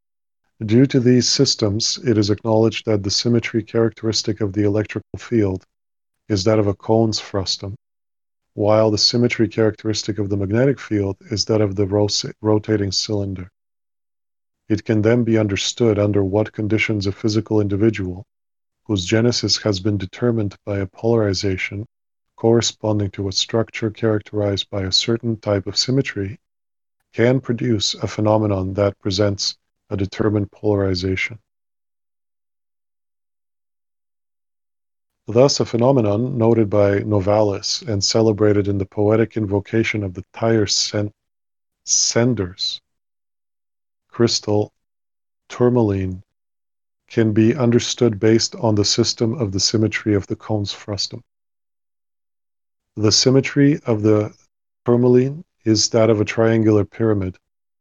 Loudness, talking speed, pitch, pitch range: -19 LUFS, 120 wpm, 110 Hz, 100-115 Hz